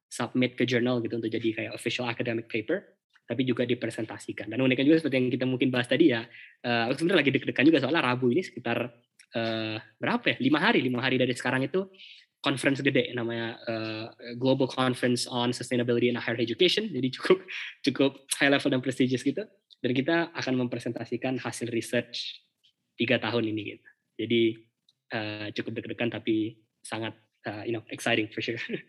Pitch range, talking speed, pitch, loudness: 115-130 Hz, 170 wpm, 120 Hz, -28 LUFS